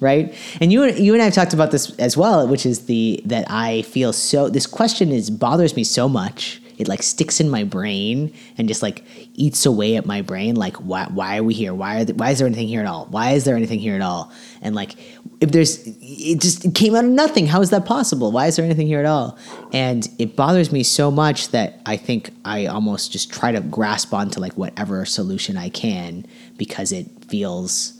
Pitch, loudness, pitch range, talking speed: 160 Hz, -19 LUFS, 125-205 Hz, 235 wpm